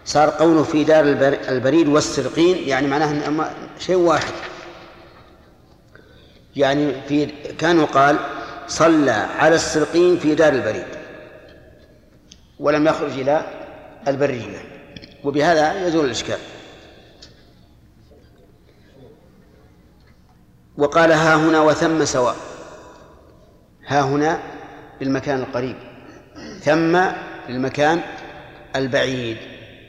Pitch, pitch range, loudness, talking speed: 145 Hz, 125-155 Hz, -18 LUFS, 80 wpm